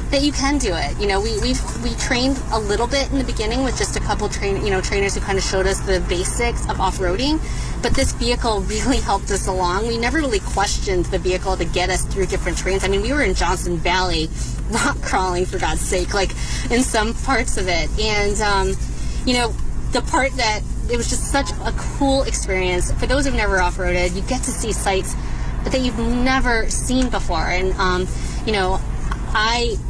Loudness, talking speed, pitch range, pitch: -20 LUFS, 215 wpm, 180-240 Hz, 195 Hz